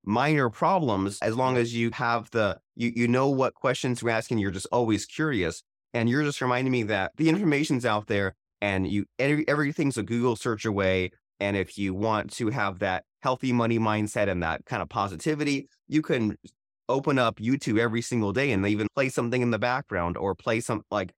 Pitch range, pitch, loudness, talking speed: 105-130 Hz, 115 Hz, -27 LUFS, 205 wpm